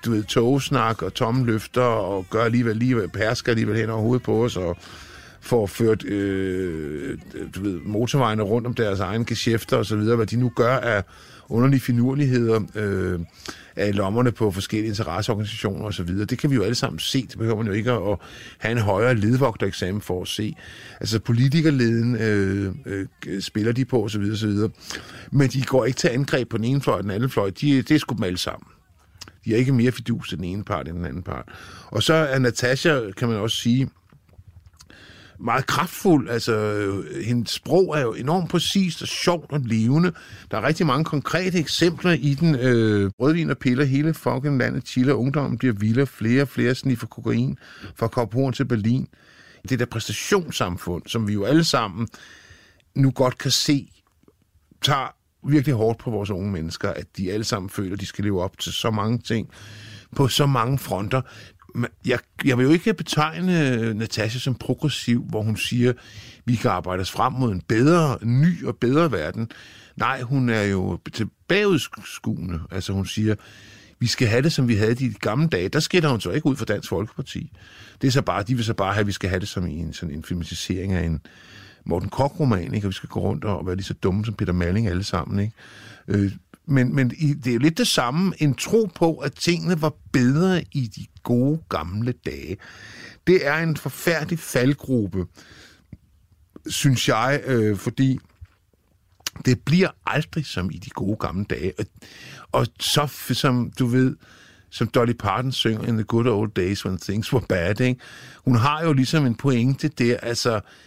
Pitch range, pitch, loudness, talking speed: 100-135 Hz, 115 Hz, -22 LUFS, 195 wpm